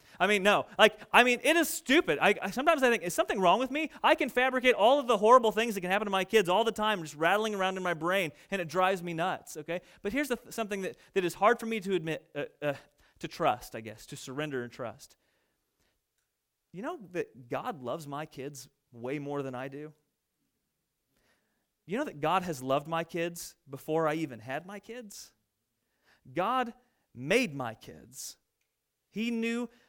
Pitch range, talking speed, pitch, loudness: 155-235 Hz, 205 wpm, 190 Hz, -29 LUFS